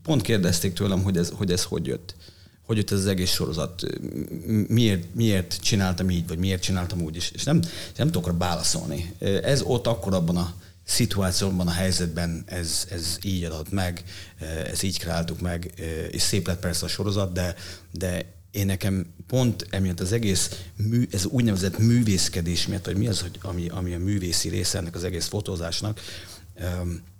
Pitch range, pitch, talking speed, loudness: 85-100 Hz, 90 Hz, 175 wpm, -25 LUFS